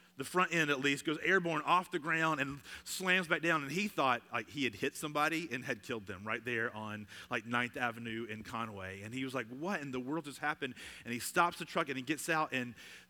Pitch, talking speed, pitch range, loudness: 140 Hz, 245 wpm, 120-160 Hz, -35 LUFS